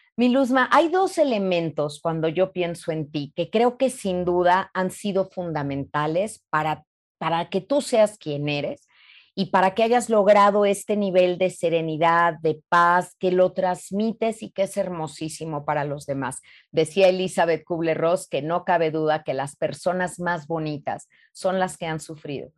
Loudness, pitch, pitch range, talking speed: -23 LUFS, 175 Hz, 160-195 Hz, 165 wpm